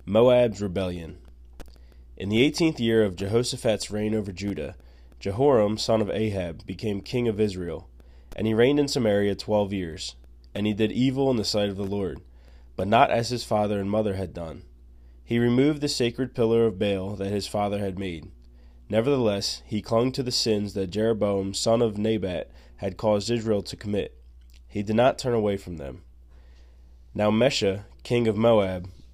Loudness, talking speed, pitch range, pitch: -25 LUFS, 175 wpm, 85-115 Hz, 100 Hz